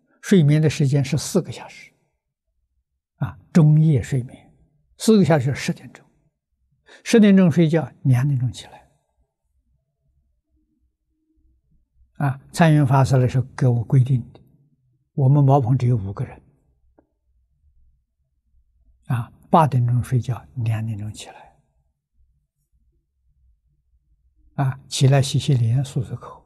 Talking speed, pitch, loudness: 170 characters per minute, 125 Hz, -19 LUFS